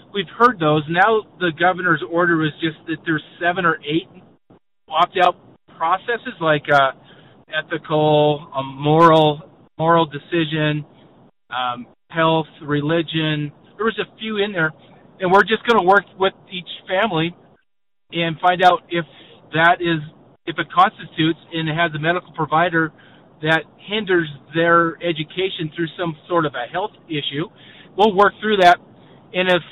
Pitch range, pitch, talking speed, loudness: 155-180 Hz, 170 Hz, 145 wpm, -19 LUFS